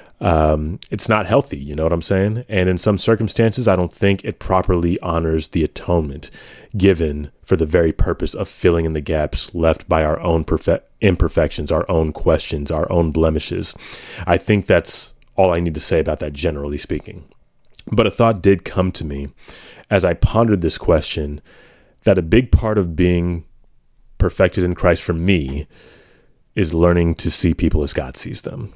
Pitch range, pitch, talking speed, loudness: 80-95 Hz, 85 Hz, 180 wpm, -18 LUFS